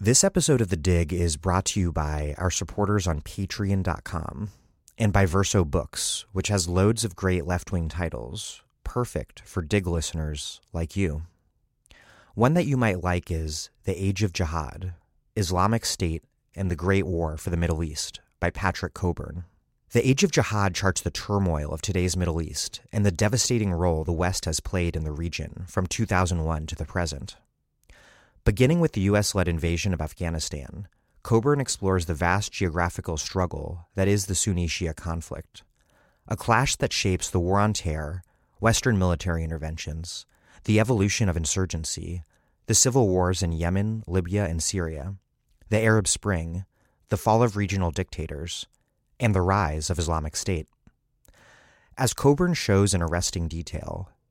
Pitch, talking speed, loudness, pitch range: 90 Hz, 160 wpm, -25 LUFS, 85-105 Hz